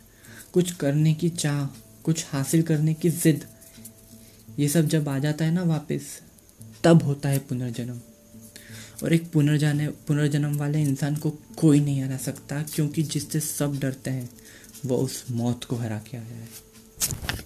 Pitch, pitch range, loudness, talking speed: 140 Hz, 115-150 Hz, -25 LUFS, 155 wpm